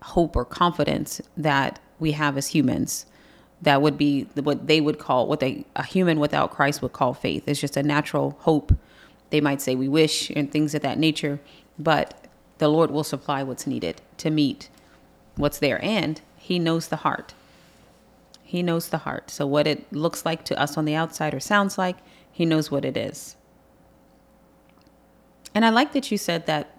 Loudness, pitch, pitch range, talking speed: -24 LUFS, 150 Hz, 145-165 Hz, 190 wpm